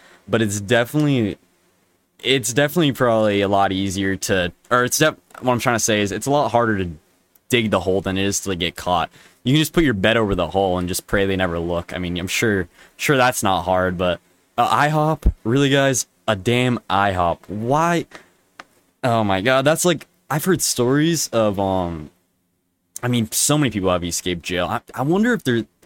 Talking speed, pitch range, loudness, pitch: 215 wpm, 90-130 Hz, -19 LUFS, 110 Hz